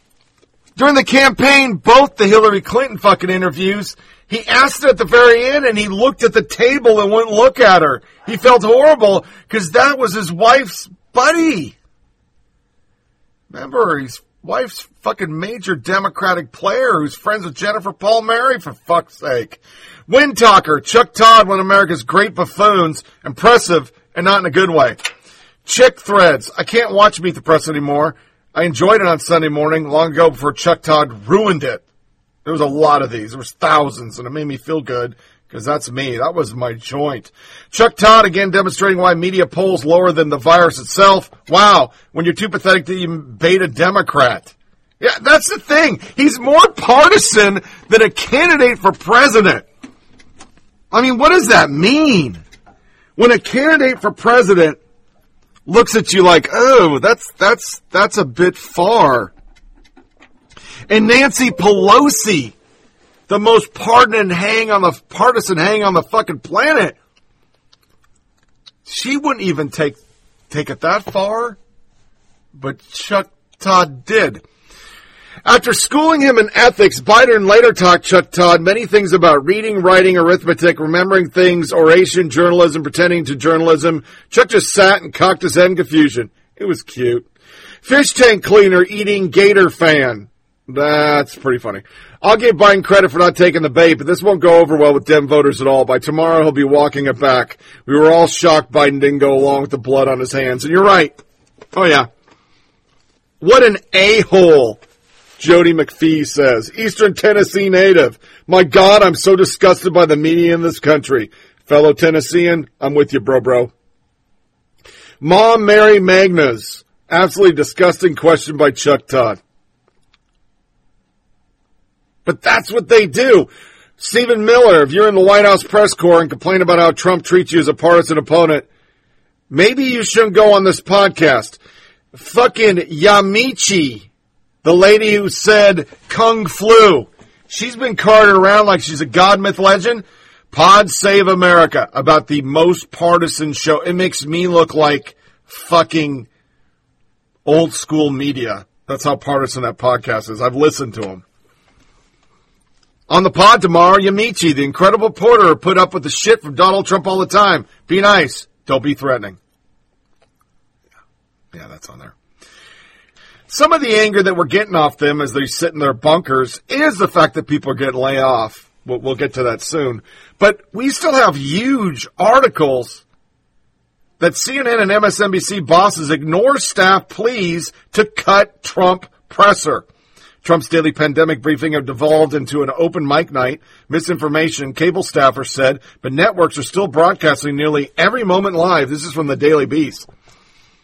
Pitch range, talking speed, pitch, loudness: 150-210 Hz, 160 wpm, 180 Hz, -12 LUFS